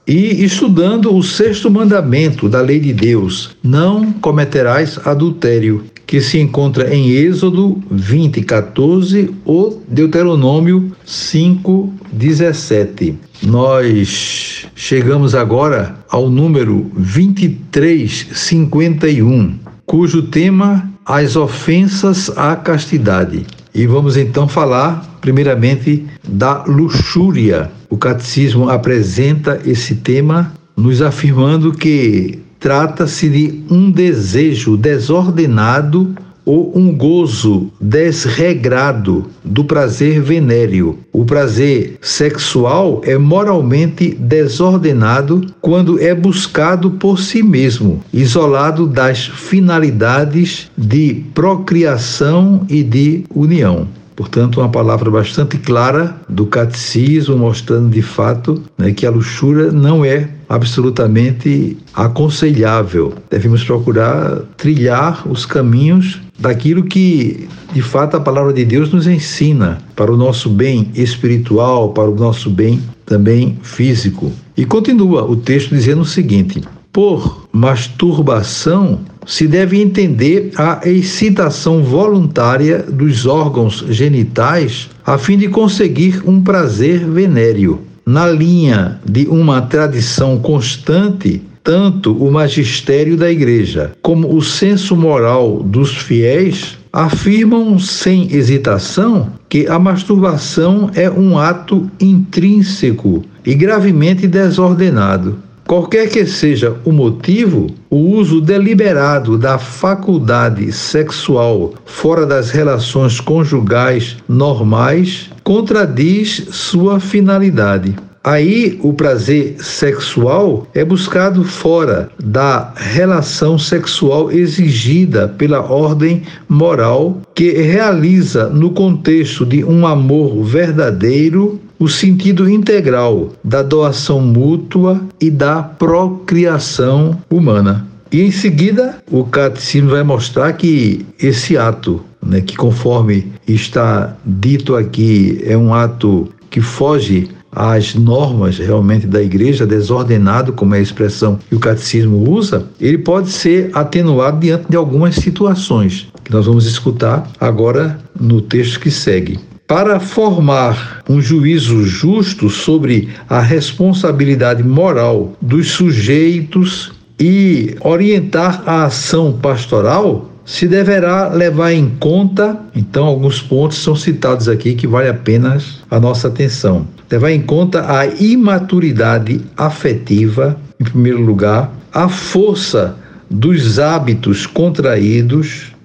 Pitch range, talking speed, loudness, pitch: 120-175 Hz, 105 wpm, -11 LUFS, 145 Hz